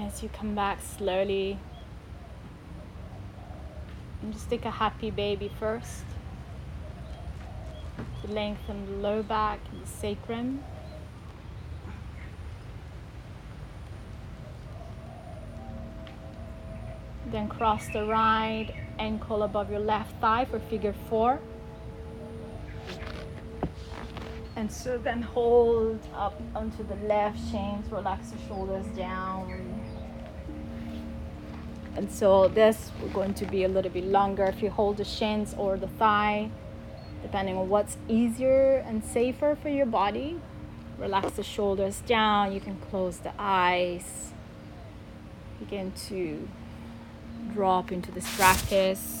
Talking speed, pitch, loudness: 105 wpm, 195 Hz, -29 LUFS